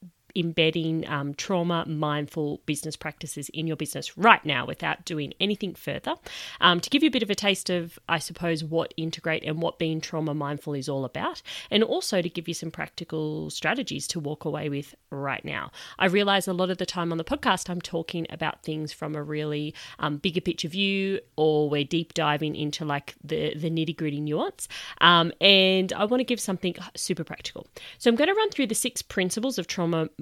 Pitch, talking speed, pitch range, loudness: 165 Hz, 205 wpm, 155-185 Hz, -26 LUFS